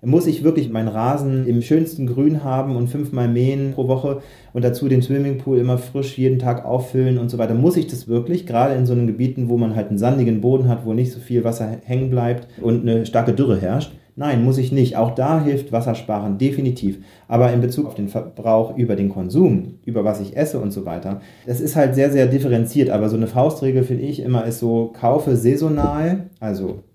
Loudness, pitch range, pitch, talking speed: -19 LUFS, 115-135 Hz, 125 Hz, 215 wpm